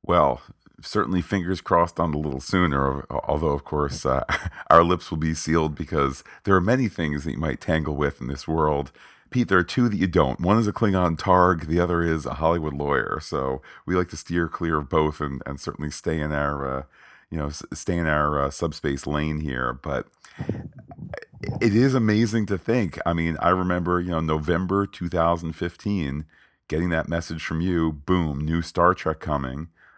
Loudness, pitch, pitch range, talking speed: -24 LUFS, 80 Hz, 75-90 Hz, 190 wpm